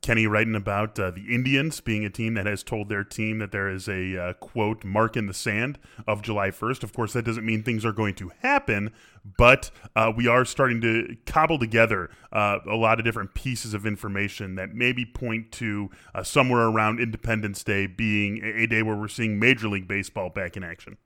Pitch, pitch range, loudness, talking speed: 110 Hz, 105-115 Hz, -25 LUFS, 210 wpm